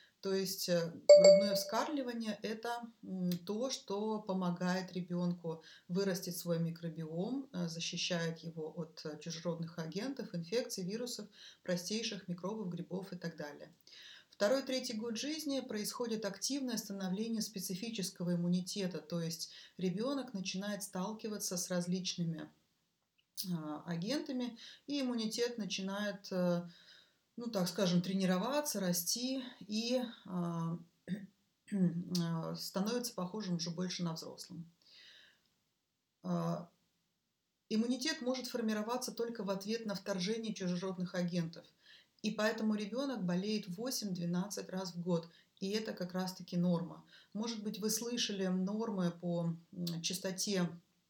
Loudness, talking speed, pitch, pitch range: -37 LUFS, 105 wpm, 190 Hz, 175-220 Hz